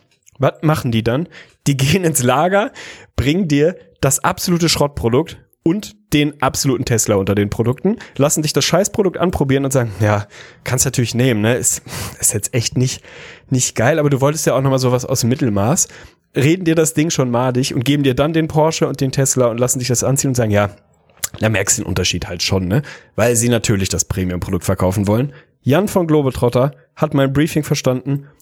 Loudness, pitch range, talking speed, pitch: -16 LUFS, 120-150 Hz, 200 wpm, 135 Hz